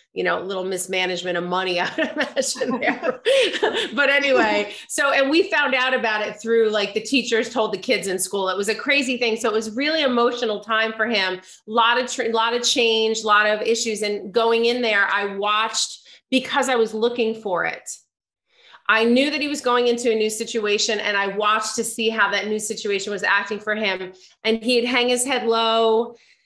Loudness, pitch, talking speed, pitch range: -20 LUFS, 225 Hz, 210 wpm, 210-250 Hz